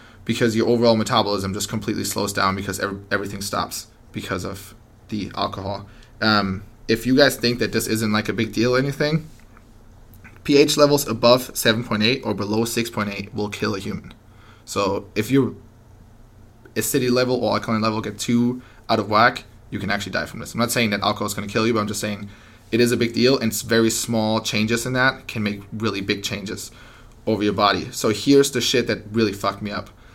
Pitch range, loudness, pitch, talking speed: 105-120 Hz, -21 LUFS, 110 Hz, 205 wpm